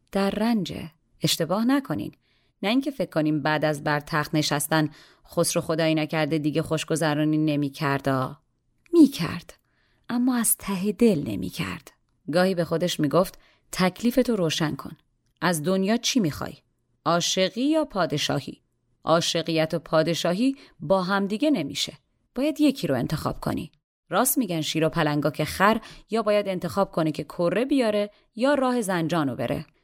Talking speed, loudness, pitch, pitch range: 145 wpm, -24 LUFS, 170 Hz, 155-210 Hz